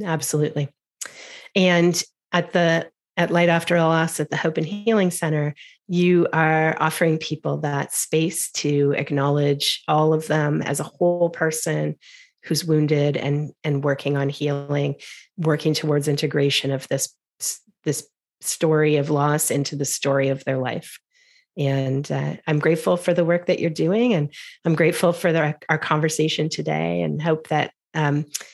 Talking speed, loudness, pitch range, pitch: 155 wpm, -21 LUFS, 145-170 Hz, 155 Hz